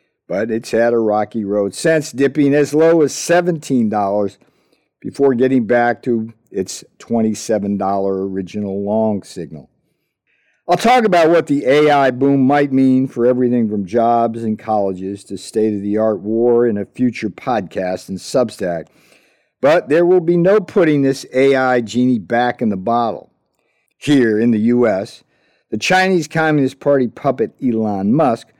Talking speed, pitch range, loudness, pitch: 150 wpm, 110-140 Hz, -16 LUFS, 120 Hz